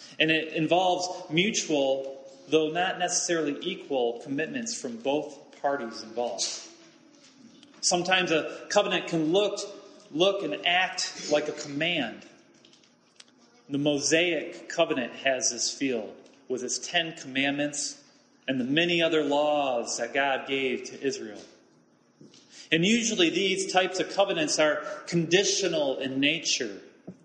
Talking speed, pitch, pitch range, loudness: 120 wpm, 165 Hz, 145-190 Hz, -27 LUFS